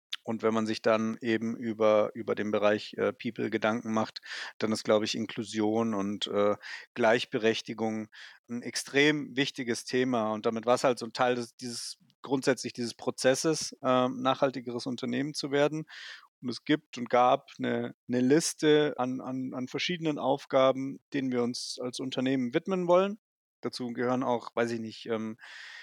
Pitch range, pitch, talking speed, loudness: 110-135 Hz, 125 Hz, 165 wpm, -30 LUFS